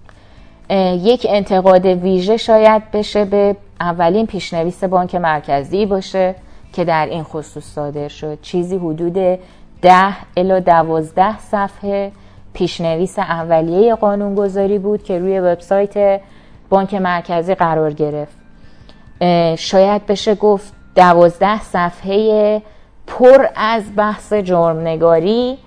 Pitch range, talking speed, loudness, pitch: 170-205 Hz, 100 wpm, -14 LUFS, 185 Hz